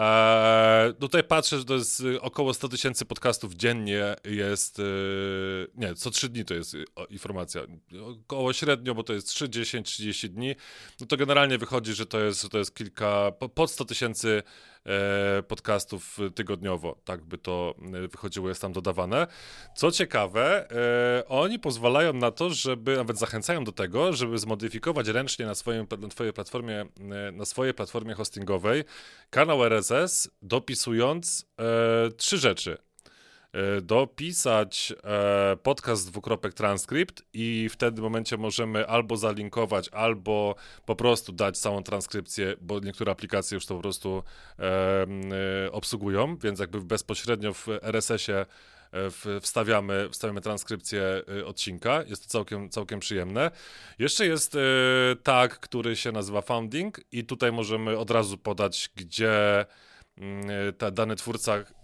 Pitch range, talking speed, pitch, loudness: 100-120 Hz, 130 wpm, 110 Hz, -27 LUFS